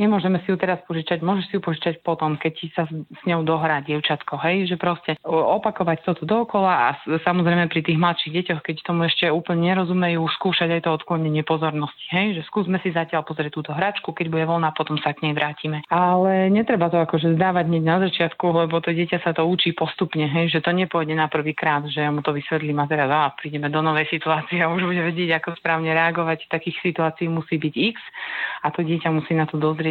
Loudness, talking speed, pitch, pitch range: -22 LUFS, 215 wpm, 165 Hz, 155-175 Hz